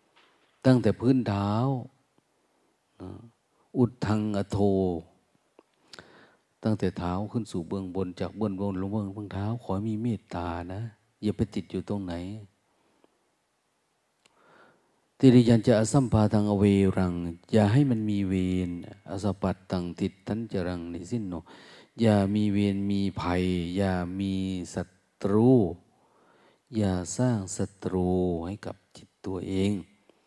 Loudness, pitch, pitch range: -27 LUFS, 100 Hz, 95-110 Hz